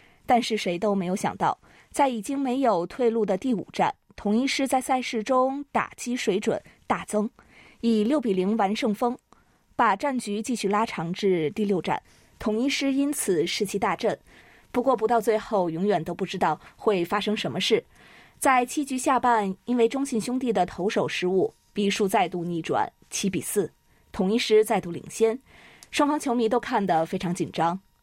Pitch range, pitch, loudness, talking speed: 195-250 Hz, 220 Hz, -25 LUFS, 255 characters per minute